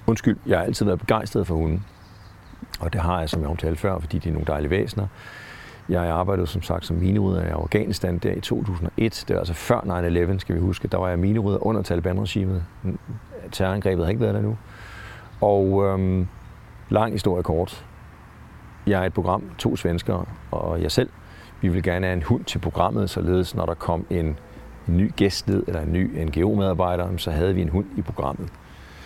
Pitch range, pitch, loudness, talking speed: 85-105 Hz, 95 Hz, -24 LUFS, 195 wpm